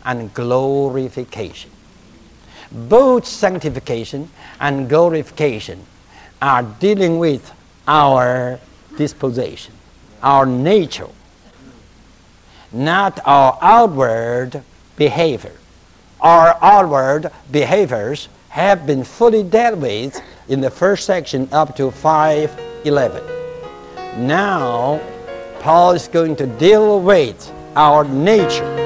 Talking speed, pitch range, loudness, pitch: 85 wpm, 125-170 Hz, -14 LUFS, 145 Hz